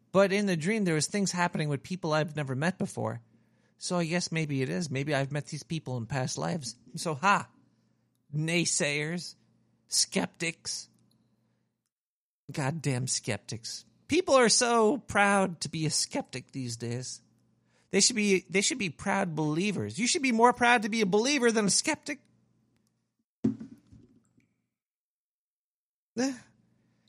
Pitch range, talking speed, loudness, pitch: 130-200 Hz, 140 wpm, -28 LUFS, 165 Hz